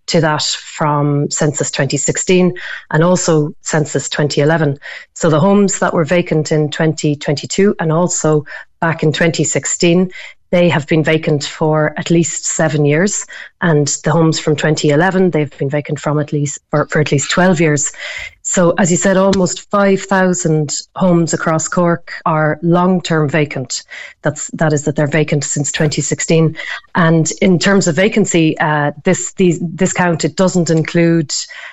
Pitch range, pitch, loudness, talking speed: 150-180 Hz, 160 Hz, -14 LUFS, 155 wpm